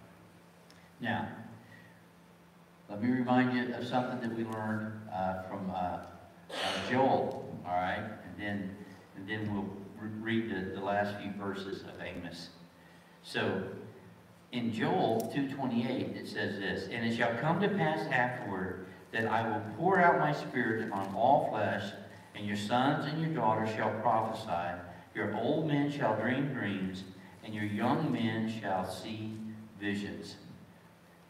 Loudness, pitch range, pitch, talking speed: -33 LUFS, 95-115 Hz, 105 Hz, 145 wpm